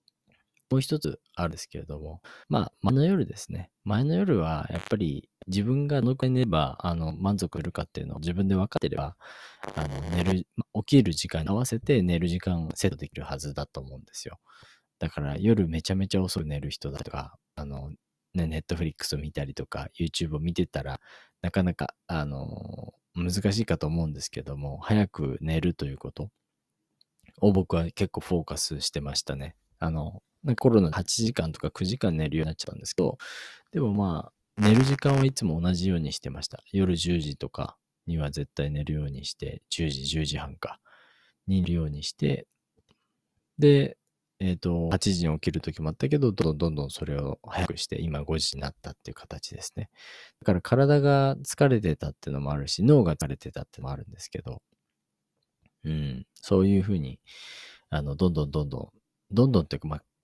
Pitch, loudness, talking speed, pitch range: 85 Hz, -28 LUFS, 360 characters per minute, 75-100 Hz